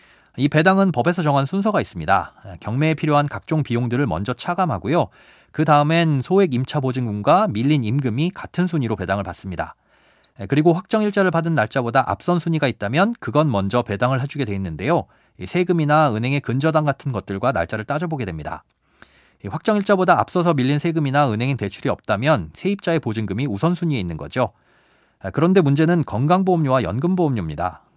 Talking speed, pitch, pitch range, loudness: 405 characters per minute, 145 Hz, 115-165 Hz, -20 LUFS